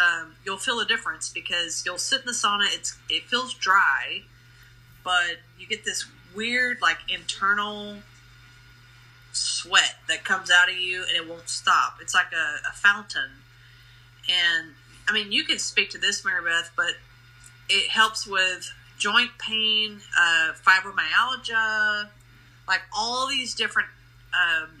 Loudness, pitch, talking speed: -23 LUFS, 175 Hz, 145 wpm